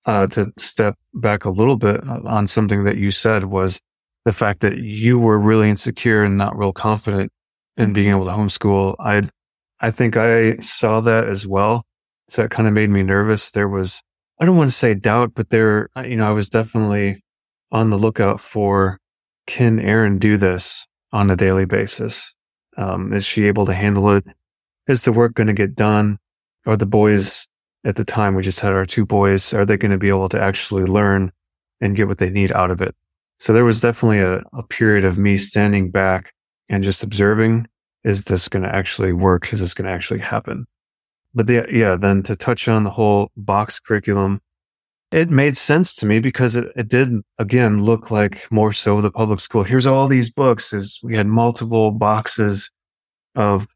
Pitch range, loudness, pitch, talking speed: 100-115 Hz, -17 LUFS, 105 Hz, 200 wpm